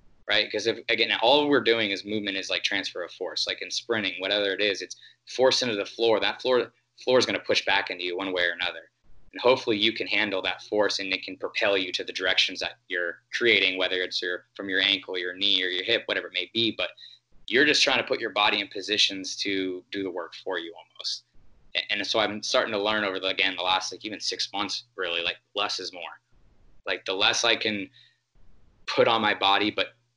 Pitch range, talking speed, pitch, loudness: 95-105 Hz, 235 wpm, 100 Hz, -25 LUFS